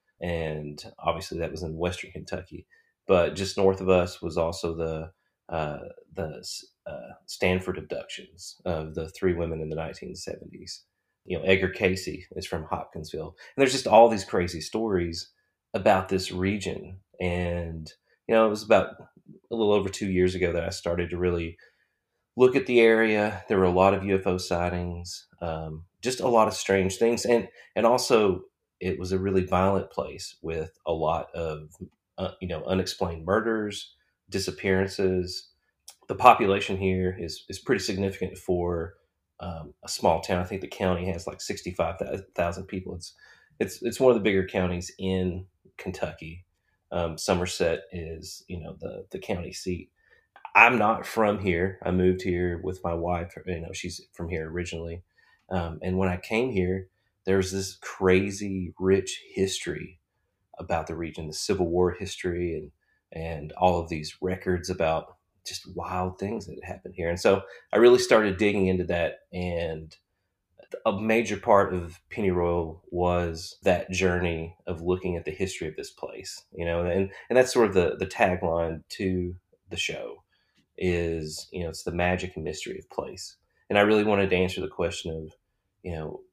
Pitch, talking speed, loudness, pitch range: 90 Hz, 170 wpm, -26 LUFS, 85-95 Hz